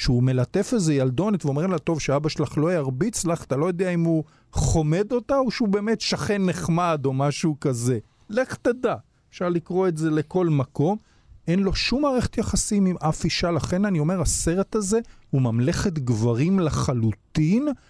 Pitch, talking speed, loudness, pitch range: 170 Hz, 175 wpm, -23 LUFS, 145-195 Hz